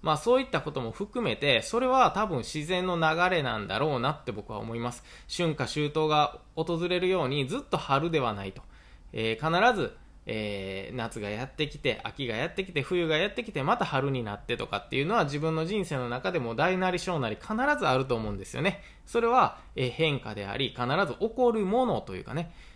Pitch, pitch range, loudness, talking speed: 150 Hz, 120-185 Hz, -29 LUFS, 380 characters per minute